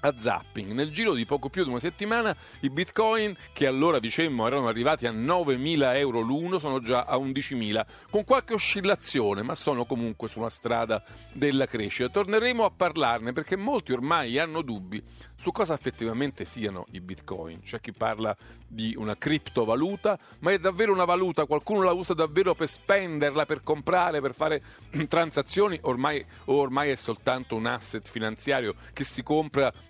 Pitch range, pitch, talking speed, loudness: 115-175 Hz, 140 Hz, 165 wpm, -27 LUFS